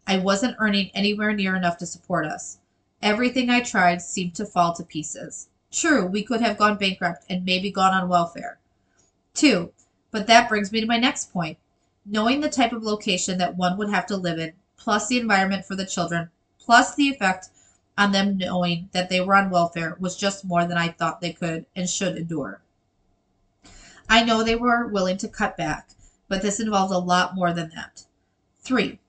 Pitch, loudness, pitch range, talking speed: 190 Hz, -22 LUFS, 170-215 Hz, 195 wpm